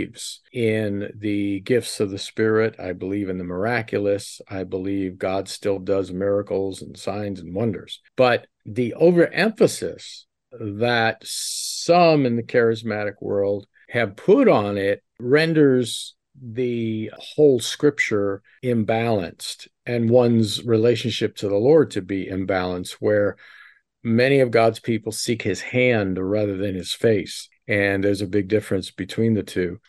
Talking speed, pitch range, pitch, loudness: 135 wpm, 100-120 Hz, 105 Hz, -21 LUFS